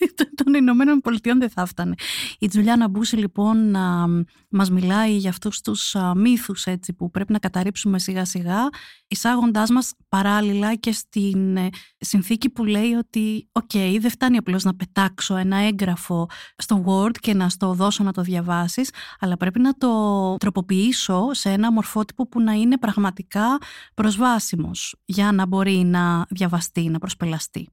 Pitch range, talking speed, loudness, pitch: 185-230 Hz, 150 wpm, -21 LUFS, 200 Hz